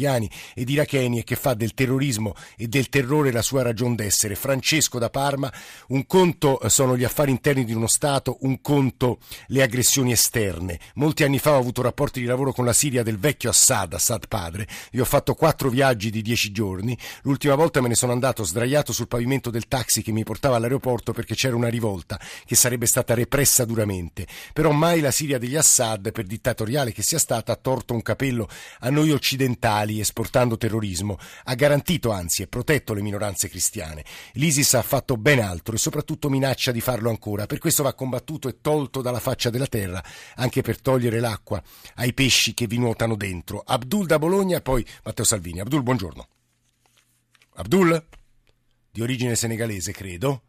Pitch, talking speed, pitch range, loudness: 125 Hz, 180 wpm, 110-135 Hz, -22 LUFS